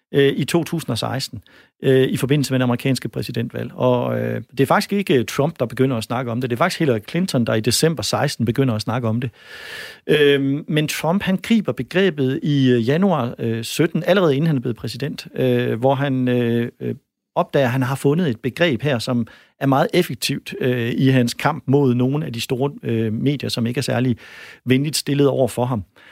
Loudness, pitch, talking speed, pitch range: -20 LUFS, 130 Hz, 180 wpm, 125-145 Hz